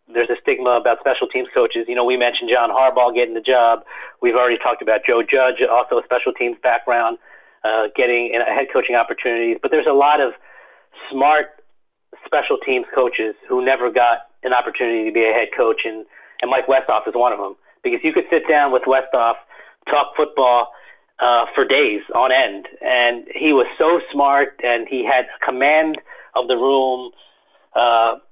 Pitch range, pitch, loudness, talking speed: 115-140 Hz, 125 Hz, -17 LUFS, 185 wpm